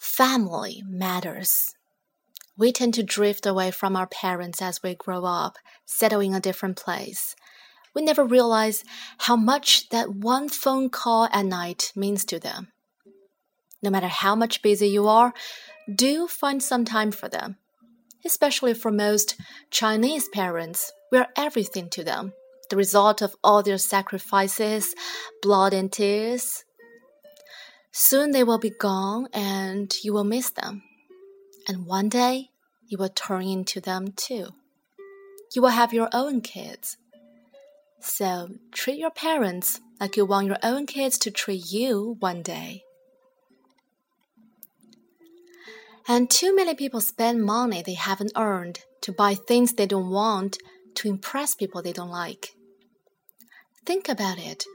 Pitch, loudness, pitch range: 220 Hz, -23 LUFS, 195-255 Hz